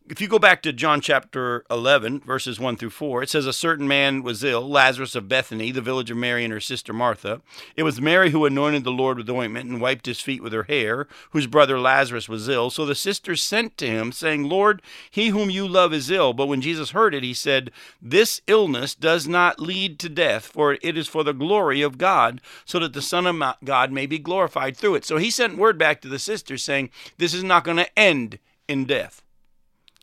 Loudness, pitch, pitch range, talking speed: -21 LUFS, 145 Hz, 130-175 Hz, 230 wpm